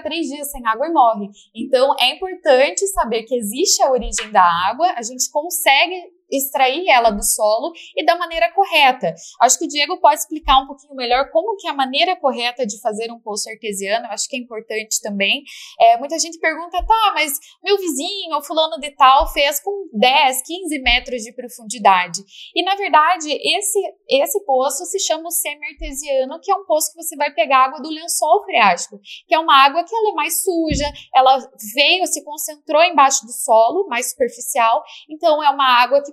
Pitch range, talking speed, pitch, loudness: 250-335 Hz, 195 wpm, 290 Hz, -17 LUFS